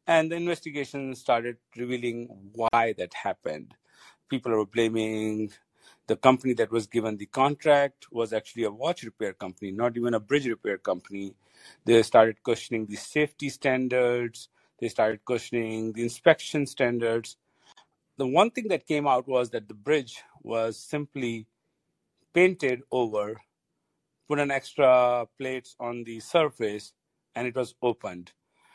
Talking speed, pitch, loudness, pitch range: 140 wpm, 120 Hz, -27 LUFS, 110-135 Hz